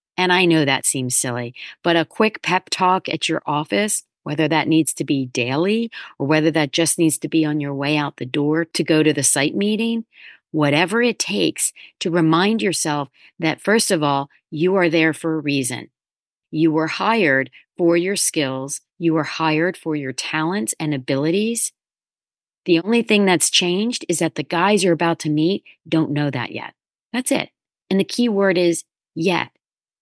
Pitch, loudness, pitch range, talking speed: 160 Hz, -19 LUFS, 145-185 Hz, 190 wpm